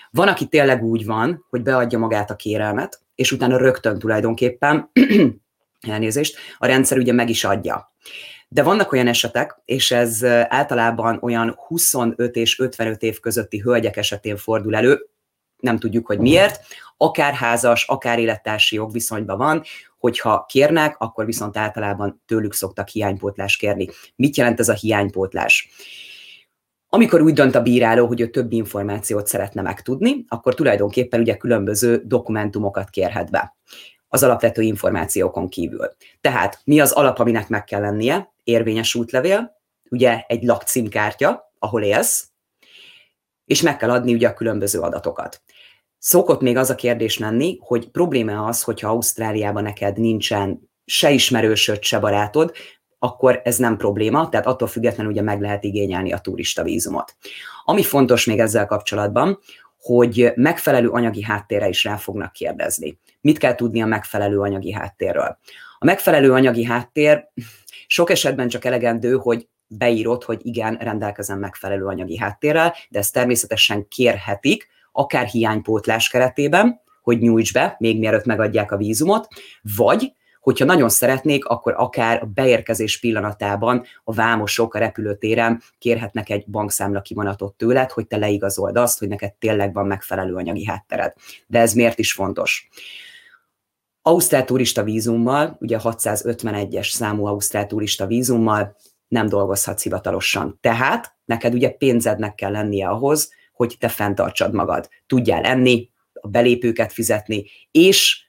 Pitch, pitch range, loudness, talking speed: 115 Hz, 105-125 Hz, -18 LUFS, 140 wpm